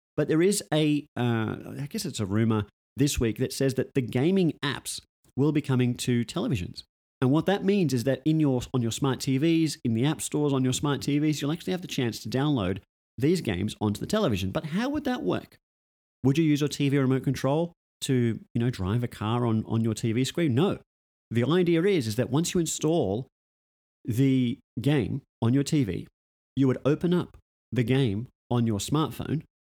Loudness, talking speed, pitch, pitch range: -27 LUFS, 205 wpm, 135 Hz, 115-150 Hz